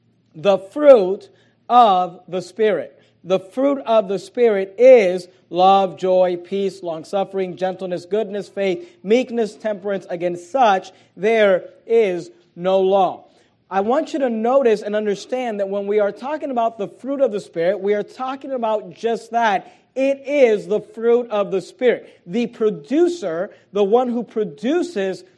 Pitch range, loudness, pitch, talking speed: 190-235 Hz, -19 LUFS, 205 Hz, 150 wpm